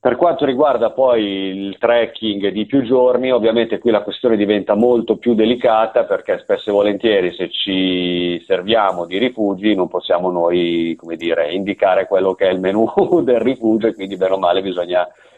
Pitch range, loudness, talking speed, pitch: 95-120 Hz, -16 LUFS, 175 wpm, 105 Hz